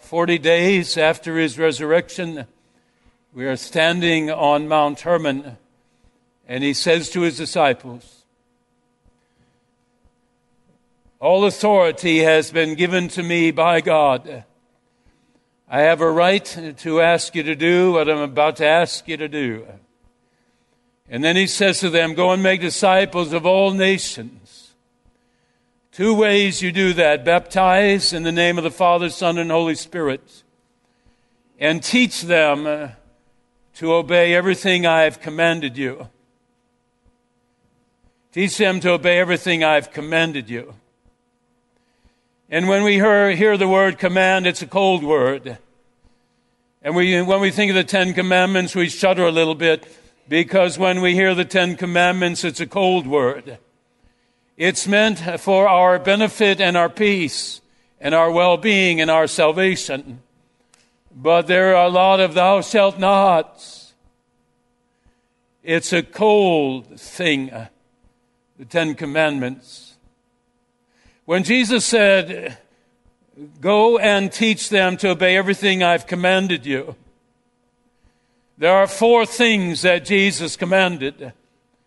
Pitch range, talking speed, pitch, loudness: 155-190 Hz, 130 wpm, 175 Hz, -17 LUFS